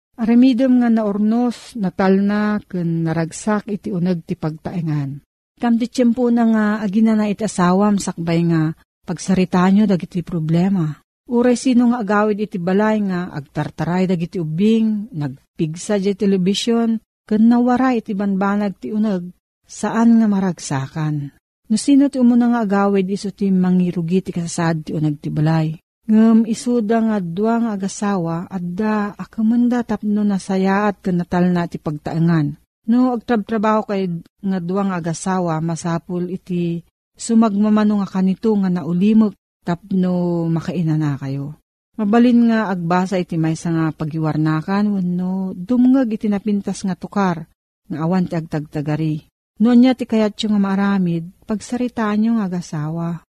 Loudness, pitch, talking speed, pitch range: -18 LUFS, 195 Hz, 135 wpm, 170-215 Hz